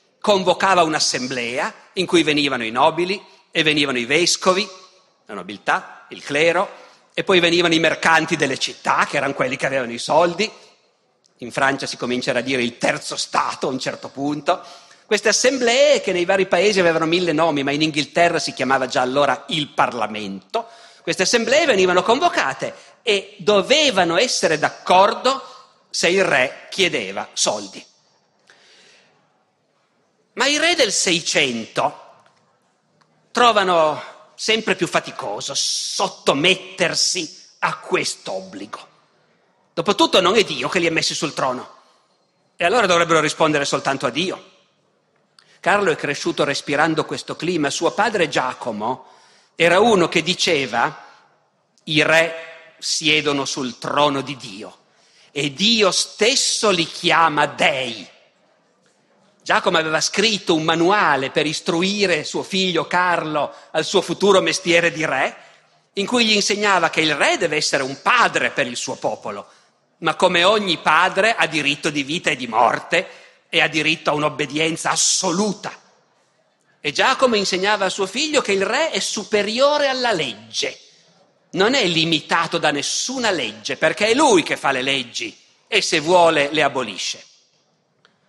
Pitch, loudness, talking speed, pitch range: 170 Hz, -18 LUFS, 140 wpm, 150-200 Hz